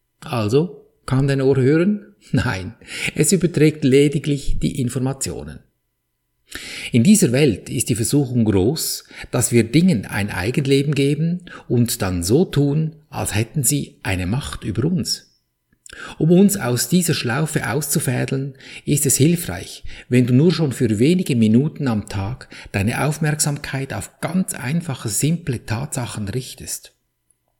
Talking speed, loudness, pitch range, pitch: 135 wpm, -19 LUFS, 120-155 Hz, 135 Hz